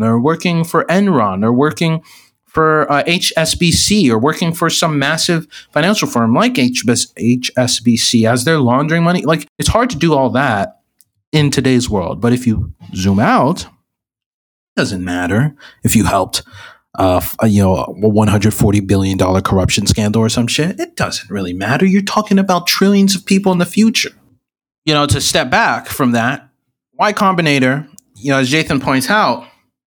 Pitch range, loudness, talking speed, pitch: 110-170 Hz, -14 LUFS, 175 wpm, 140 Hz